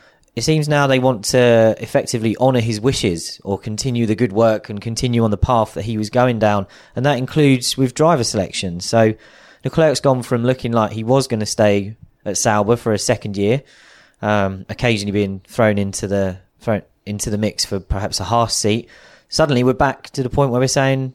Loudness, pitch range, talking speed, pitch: -18 LUFS, 105-130 Hz, 205 wpm, 115 Hz